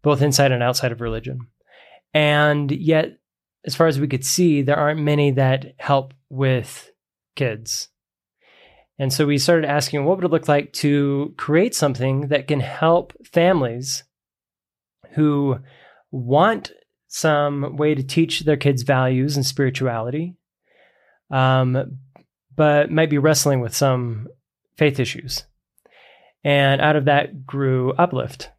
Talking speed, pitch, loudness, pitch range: 135 wpm, 145 Hz, -19 LUFS, 130-150 Hz